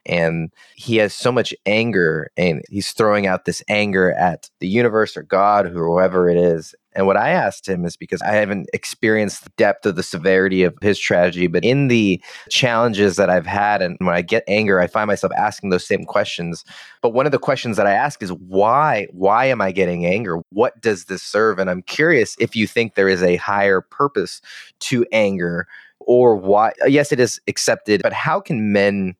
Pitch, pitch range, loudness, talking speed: 100 Hz, 90-105 Hz, -18 LUFS, 205 wpm